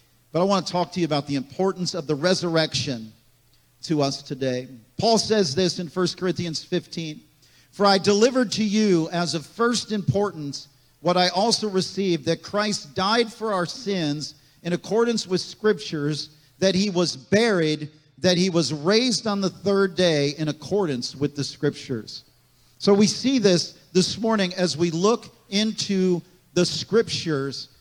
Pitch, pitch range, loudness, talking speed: 175 Hz, 150-200 Hz, -23 LUFS, 160 wpm